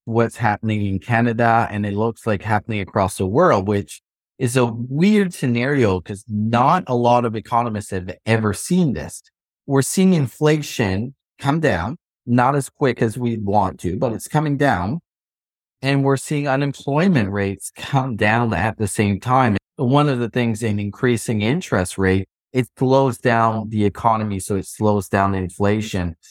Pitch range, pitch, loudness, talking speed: 105-130 Hz, 115 Hz, -19 LUFS, 165 wpm